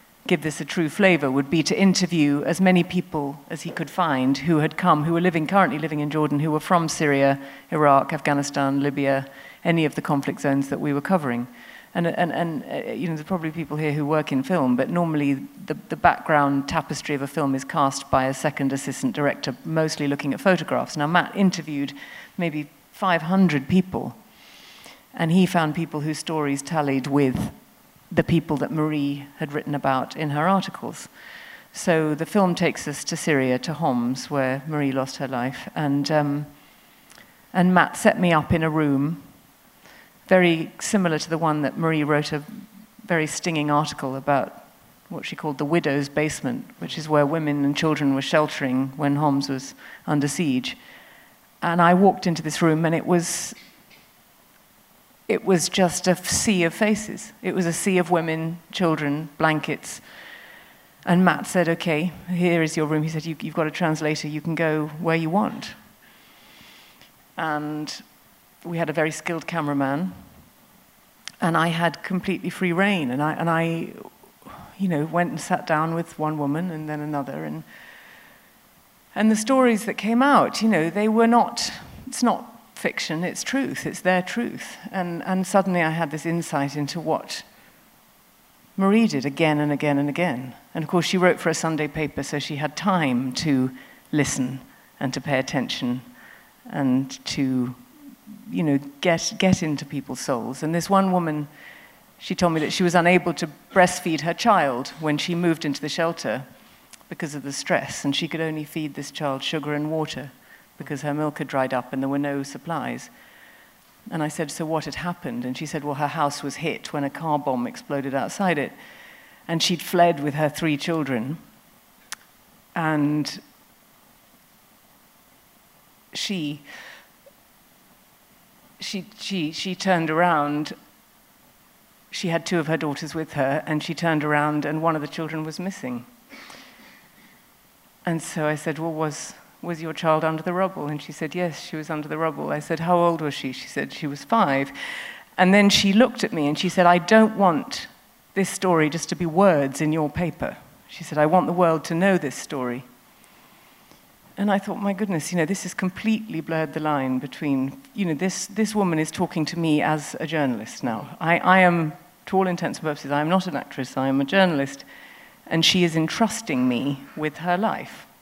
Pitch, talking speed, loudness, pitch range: 160 Hz, 180 wpm, -23 LUFS, 145-180 Hz